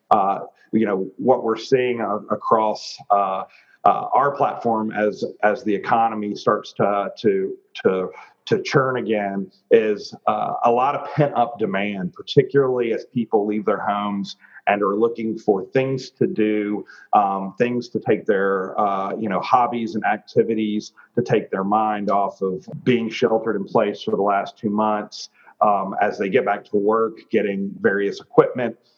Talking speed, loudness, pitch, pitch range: 170 wpm, -21 LUFS, 110 Hz, 105-125 Hz